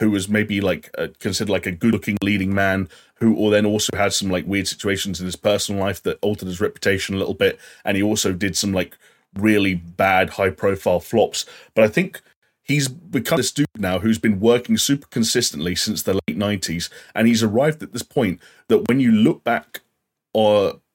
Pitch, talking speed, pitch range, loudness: 105 Hz, 205 wpm, 95-115 Hz, -20 LUFS